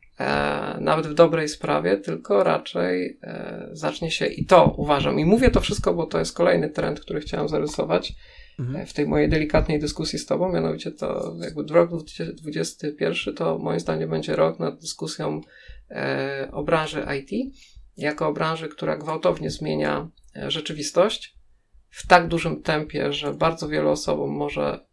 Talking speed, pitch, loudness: 145 wpm, 135 Hz, -23 LUFS